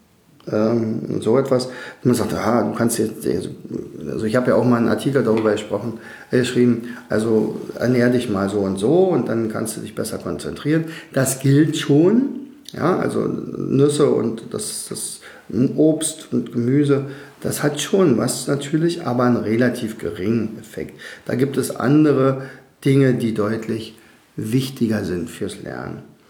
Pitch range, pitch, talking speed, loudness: 110-140 Hz, 120 Hz, 150 wpm, -20 LUFS